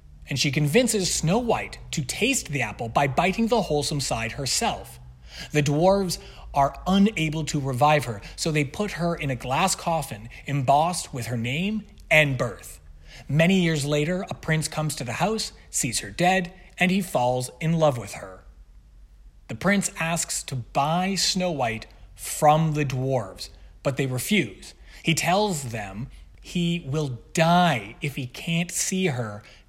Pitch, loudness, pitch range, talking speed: 150 Hz, -24 LUFS, 125-175 Hz, 160 wpm